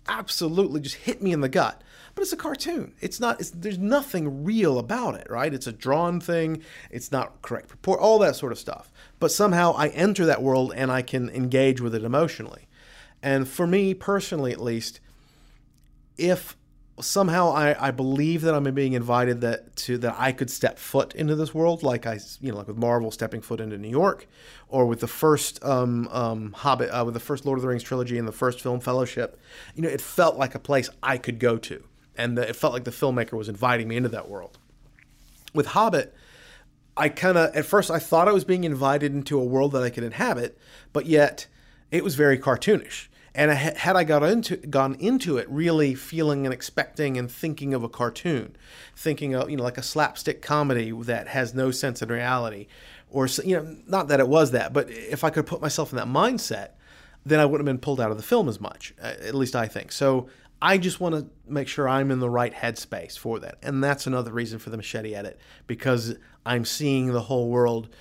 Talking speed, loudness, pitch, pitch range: 215 wpm, -25 LUFS, 135 Hz, 125-160 Hz